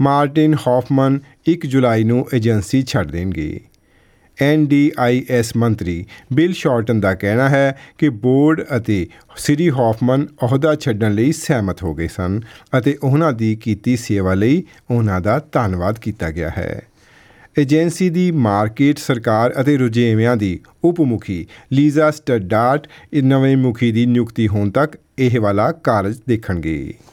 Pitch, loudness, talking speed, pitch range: 125 Hz, -17 LUFS, 135 wpm, 110-145 Hz